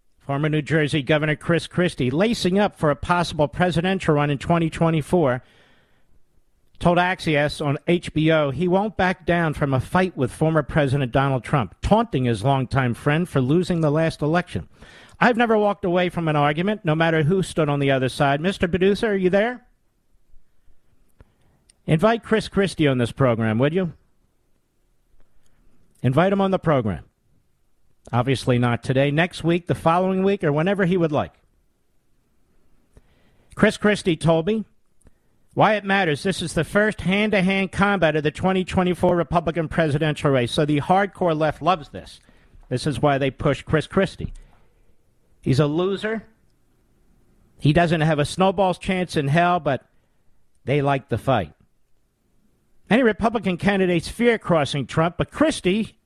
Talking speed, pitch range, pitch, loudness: 150 wpm, 145-185 Hz, 165 Hz, -21 LUFS